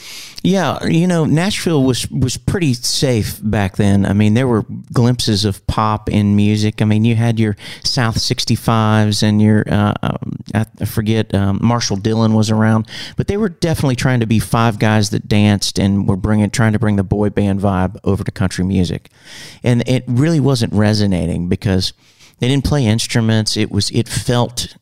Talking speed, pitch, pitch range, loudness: 175 wpm, 110 Hz, 105-120 Hz, -15 LUFS